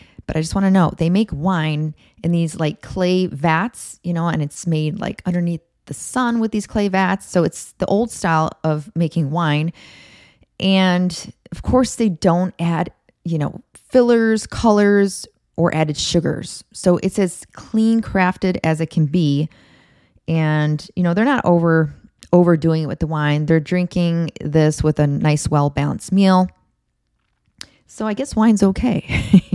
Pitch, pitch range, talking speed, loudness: 175 Hz, 155-195 Hz, 165 wpm, -18 LUFS